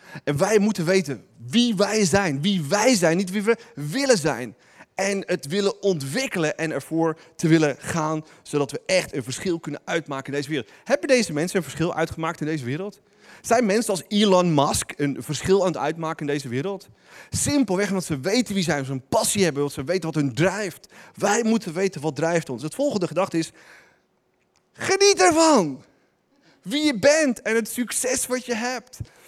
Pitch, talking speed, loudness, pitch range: 185 Hz, 195 wpm, -23 LUFS, 155-215 Hz